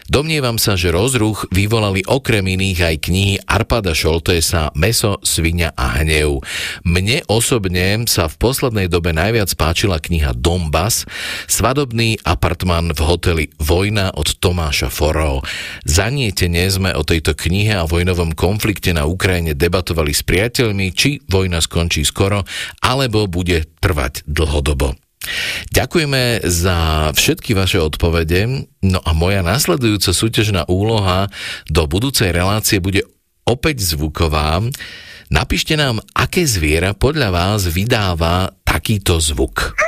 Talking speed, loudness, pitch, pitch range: 120 wpm, -16 LUFS, 95 Hz, 85-110 Hz